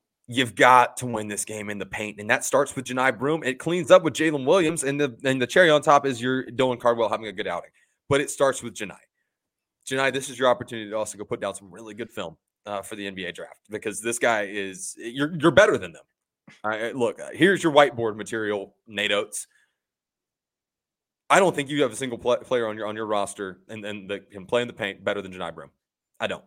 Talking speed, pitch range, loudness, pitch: 245 wpm, 105-135 Hz, -23 LUFS, 120 Hz